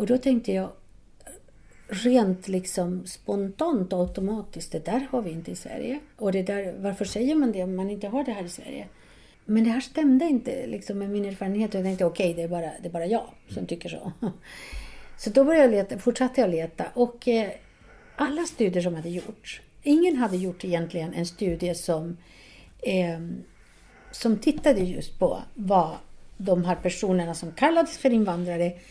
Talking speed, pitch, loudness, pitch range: 185 wpm, 200 Hz, -26 LUFS, 180-250 Hz